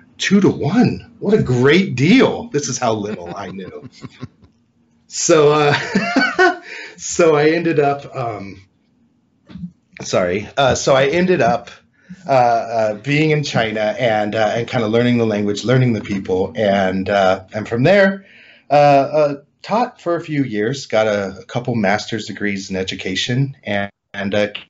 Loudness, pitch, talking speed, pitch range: -16 LUFS, 125 Hz, 160 wpm, 105-155 Hz